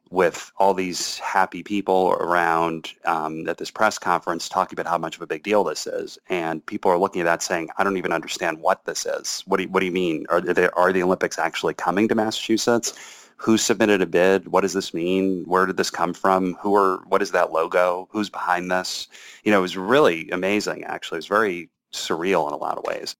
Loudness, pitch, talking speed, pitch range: -22 LUFS, 95 Hz, 230 wpm, 90-110 Hz